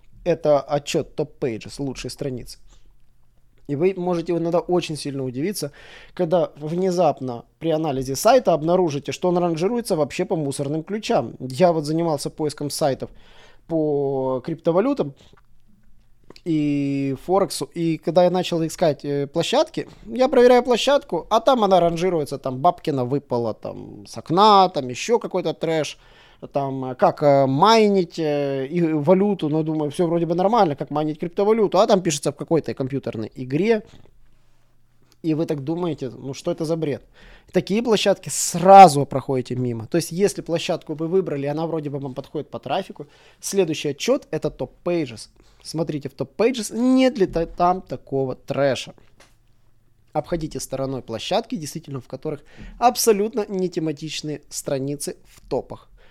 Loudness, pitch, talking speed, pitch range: -21 LUFS, 155 Hz, 140 wpm, 135-180 Hz